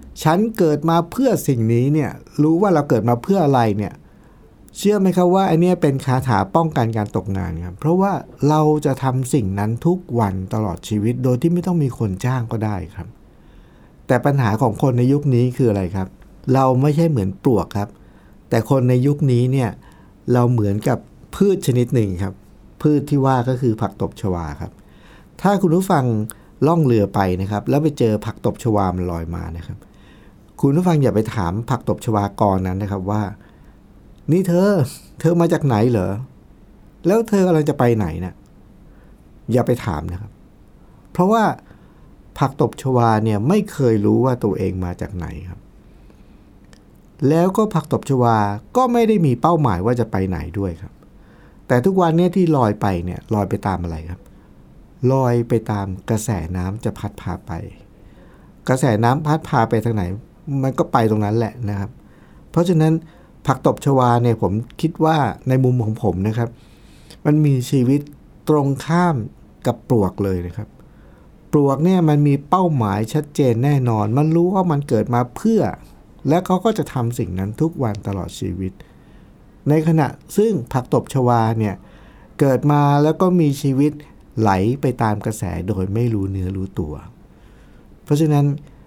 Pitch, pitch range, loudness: 125 Hz, 105-150 Hz, -18 LUFS